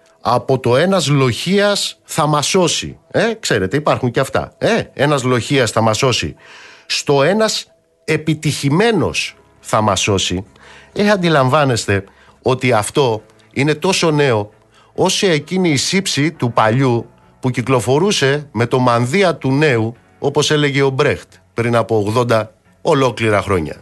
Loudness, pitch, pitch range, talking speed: -15 LUFS, 135 Hz, 110-155 Hz, 135 wpm